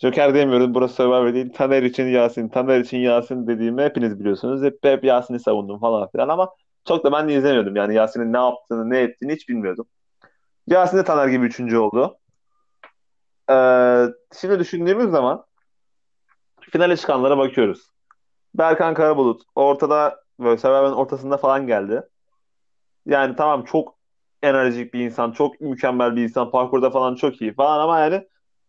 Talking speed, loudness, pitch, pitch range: 150 wpm, -19 LUFS, 130 Hz, 120-145 Hz